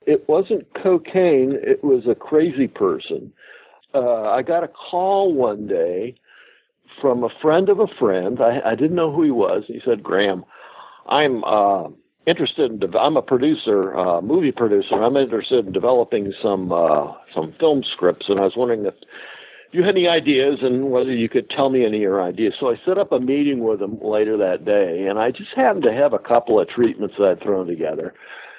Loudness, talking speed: -19 LUFS, 200 wpm